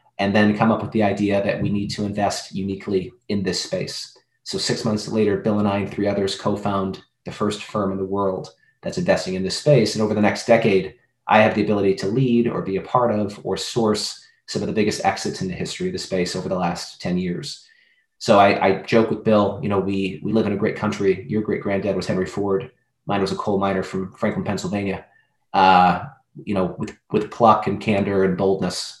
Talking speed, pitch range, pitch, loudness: 230 wpm, 95-110 Hz, 100 Hz, -21 LUFS